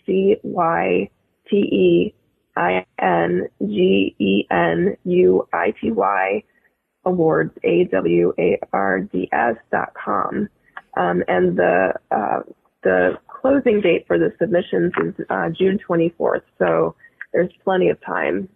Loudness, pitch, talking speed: -19 LUFS, 165 Hz, 135 wpm